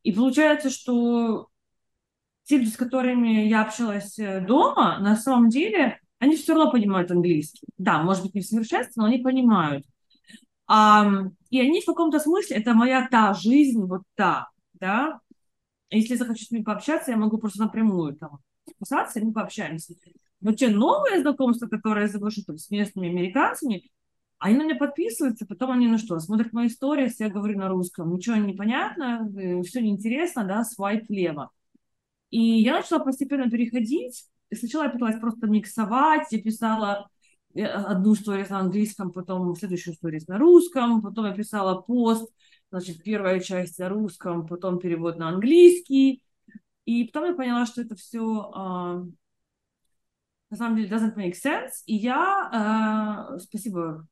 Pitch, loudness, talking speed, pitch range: 220 Hz, -23 LUFS, 155 wpm, 195-250 Hz